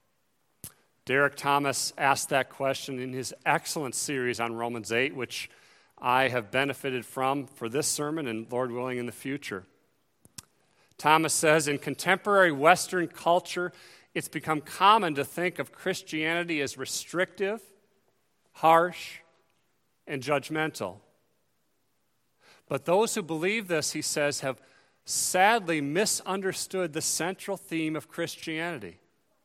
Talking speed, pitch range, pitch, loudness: 120 wpm, 135-175 Hz, 155 Hz, -27 LUFS